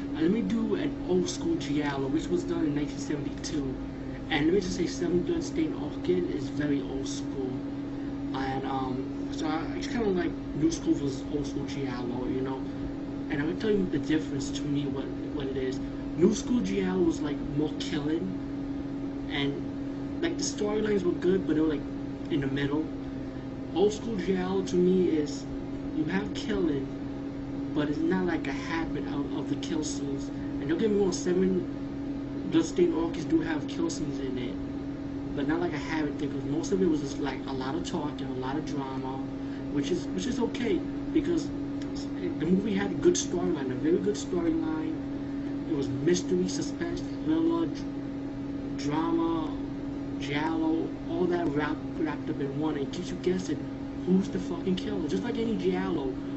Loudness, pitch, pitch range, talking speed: -30 LUFS, 140 Hz, 140-225 Hz, 185 wpm